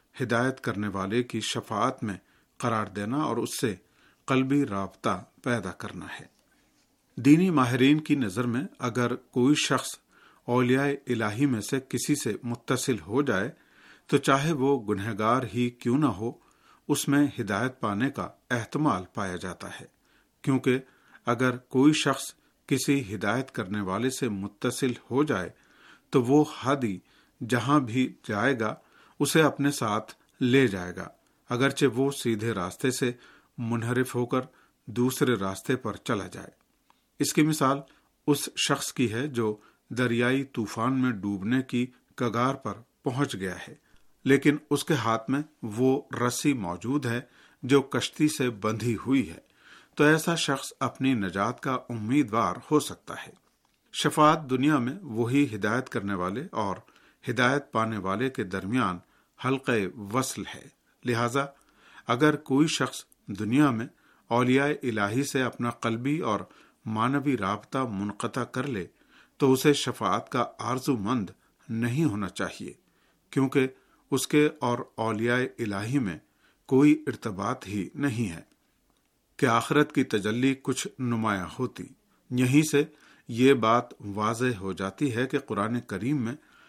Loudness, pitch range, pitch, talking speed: -27 LUFS, 115-140 Hz, 125 Hz, 140 wpm